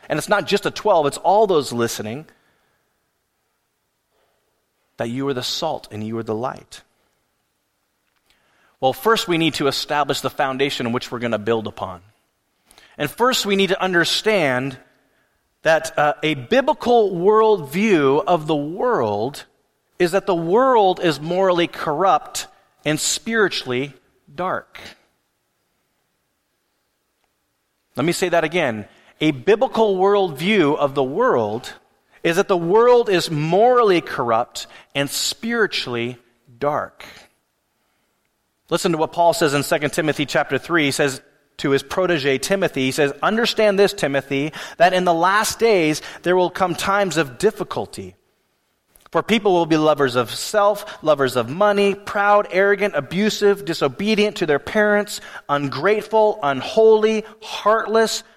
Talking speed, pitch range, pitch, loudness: 135 wpm, 140-205 Hz, 170 Hz, -19 LUFS